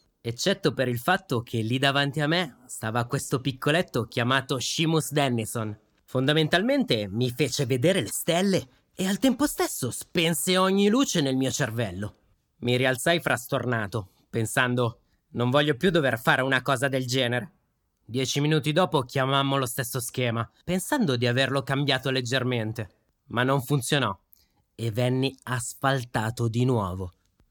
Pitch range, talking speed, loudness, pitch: 120-150 Hz, 140 wpm, -25 LUFS, 130 Hz